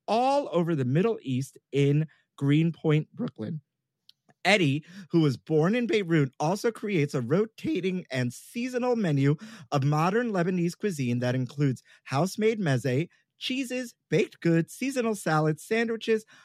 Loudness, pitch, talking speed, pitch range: -27 LUFS, 170 Hz, 130 wpm, 145-220 Hz